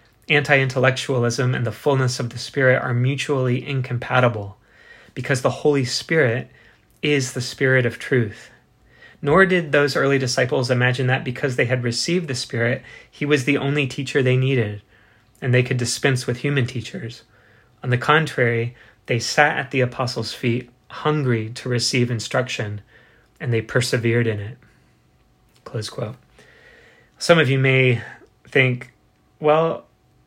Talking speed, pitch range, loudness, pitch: 145 wpm, 120-140 Hz, -20 LUFS, 125 Hz